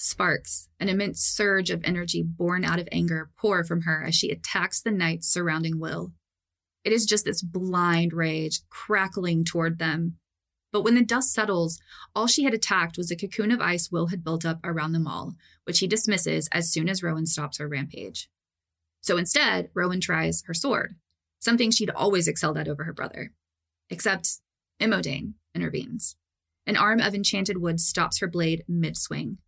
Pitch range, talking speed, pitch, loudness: 155-195 Hz, 175 wpm, 170 Hz, -24 LUFS